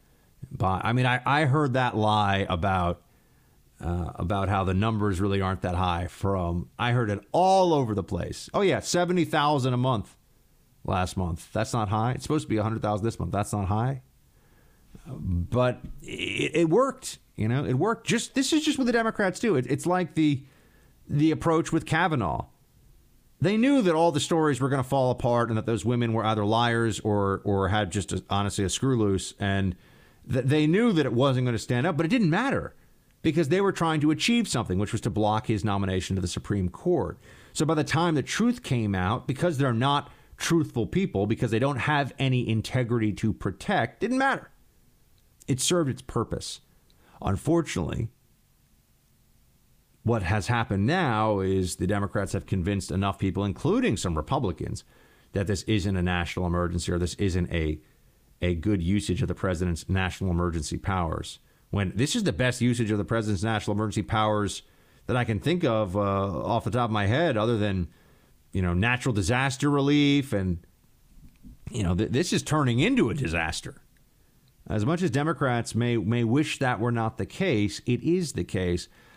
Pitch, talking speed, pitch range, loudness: 115 Hz, 190 wpm, 100-140 Hz, -26 LUFS